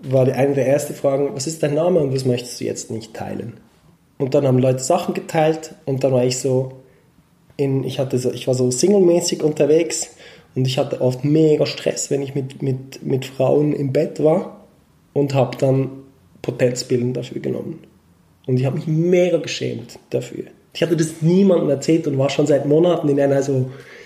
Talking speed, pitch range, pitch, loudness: 190 wpm, 130-155 Hz, 140 Hz, -19 LUFS